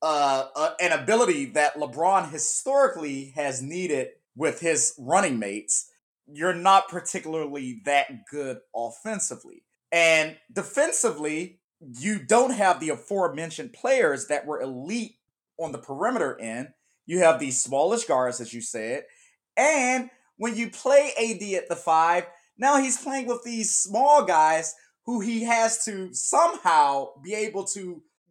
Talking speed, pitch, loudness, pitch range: 140 wpm, 180 Hz, -24 LUFS, 150-235 Hz